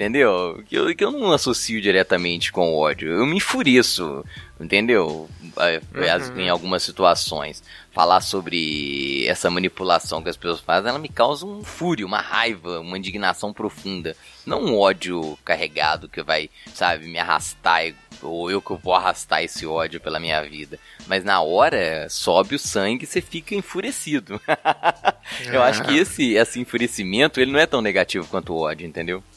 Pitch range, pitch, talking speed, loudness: 80-115 Hz, 90 Hz, 160 wpm, -21 LUFS